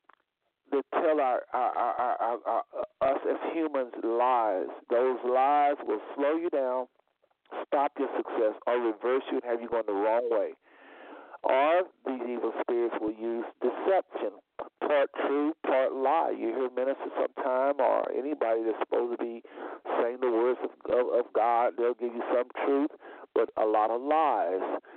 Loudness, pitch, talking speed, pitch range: -29 LUFS, 130 Hz, 165 wpm, 120-155 Hz